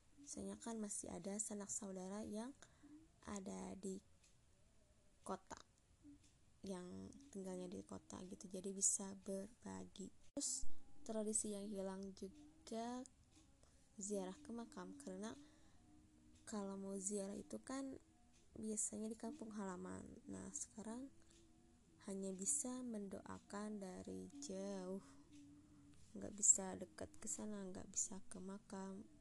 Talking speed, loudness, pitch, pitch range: 105 wpm, -47 LUFS, 195 Hz, 180-215 Hz